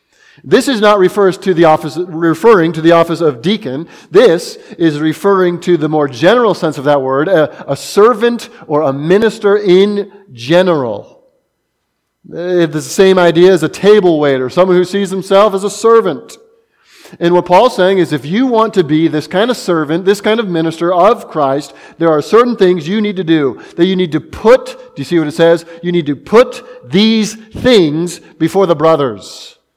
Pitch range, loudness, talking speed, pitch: 160-210 Hz, -11 LUFS, 190 wpm, 180 Hz